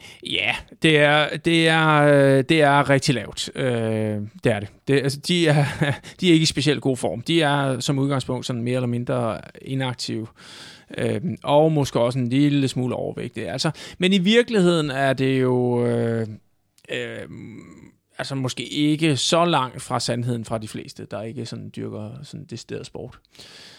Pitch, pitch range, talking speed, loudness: 135 Hz, 120-150 Hz, 170 wpm, -21 LUFS